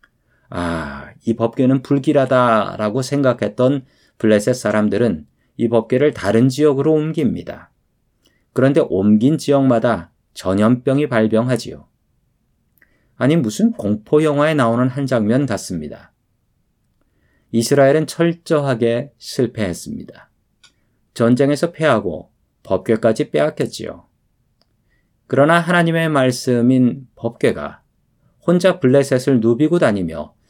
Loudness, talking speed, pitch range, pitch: -17 LUFS, 255 characters per minute, 115-145 Hz, 130 Hz